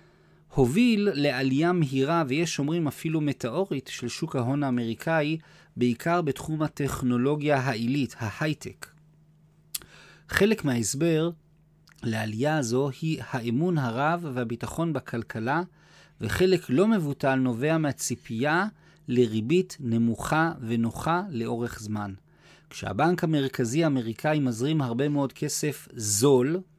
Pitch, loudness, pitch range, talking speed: 145 Hz, -27 LUFS, 125-160 Hz, 95 wpm